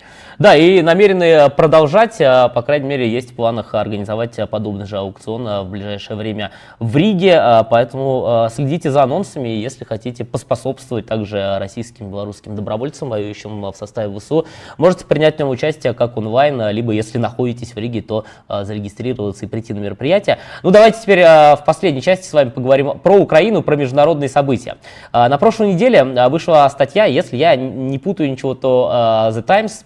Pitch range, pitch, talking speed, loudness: 110-150 Hz, 125 Hz, 165 wpm, -14 LUFS